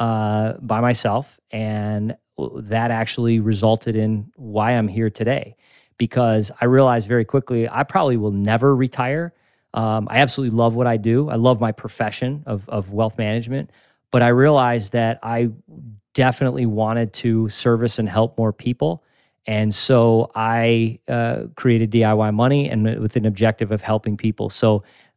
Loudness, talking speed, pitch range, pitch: -19 LUFS, 155 wpm, 110-120 Hz, 115 Hz